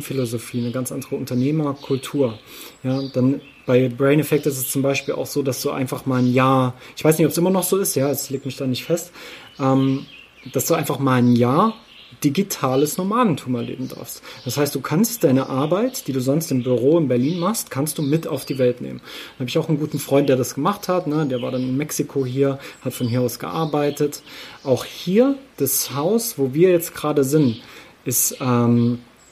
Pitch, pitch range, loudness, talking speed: 140 Hz, 130-155 Hz, -20 LUFS, 215 wpm